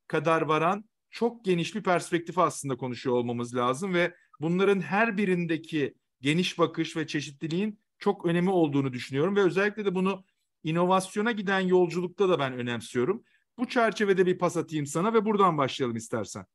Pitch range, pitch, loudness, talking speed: 150-195 Hz, 175 Hz, -27 LUFS, 150 wpm